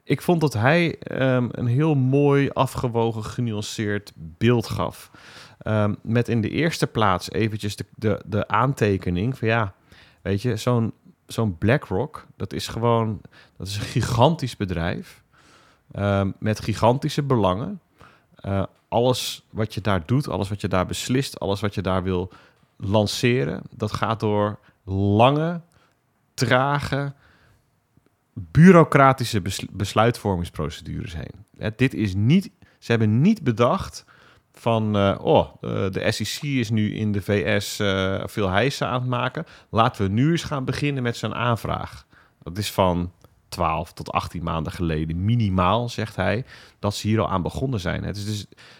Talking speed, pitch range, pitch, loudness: 150 wpm, 100-130 Hz, 110 Hz, -23 LUFS